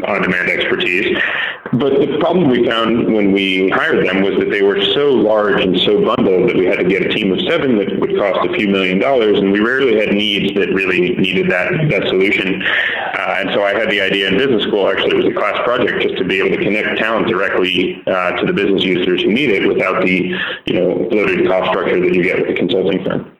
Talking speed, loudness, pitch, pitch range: 240 wpm, -14 LUFS, 100 Hz, 95-135 Hz